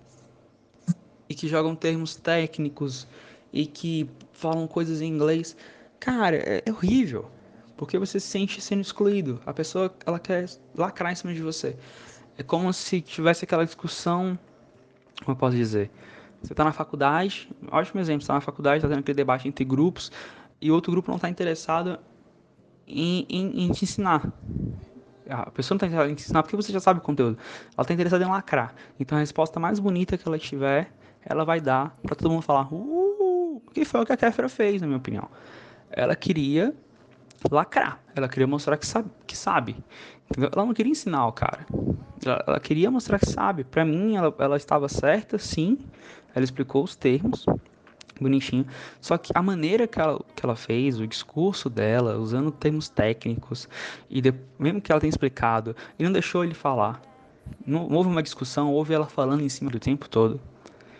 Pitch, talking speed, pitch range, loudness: 155 Hz, 180 wpm, 135-180 Hz, -26 LUFS